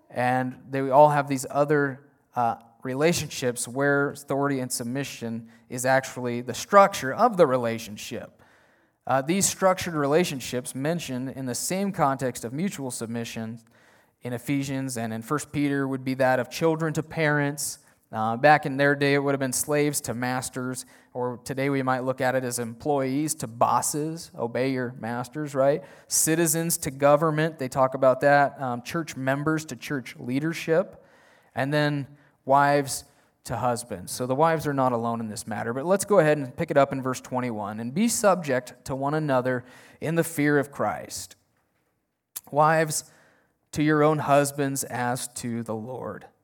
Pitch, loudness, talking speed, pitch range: 135 Hz, -25 LUFS, 165 wpm, 125-150 Hz